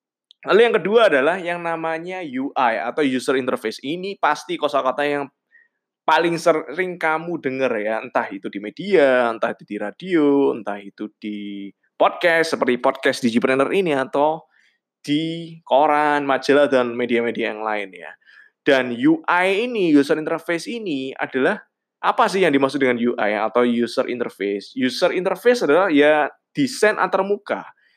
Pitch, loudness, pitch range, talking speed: 145 Hz, -20 LUFS, 125-175 Hz, 140 wpm